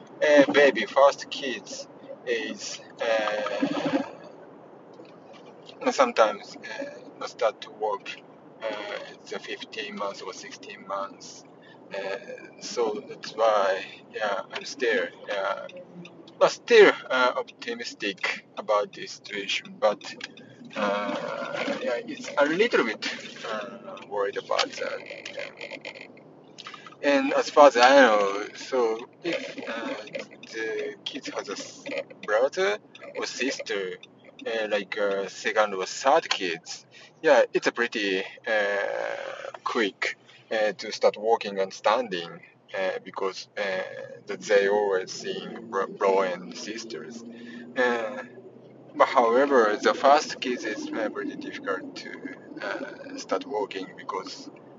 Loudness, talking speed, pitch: -26 LUFS, 115 wpm, 280 Hz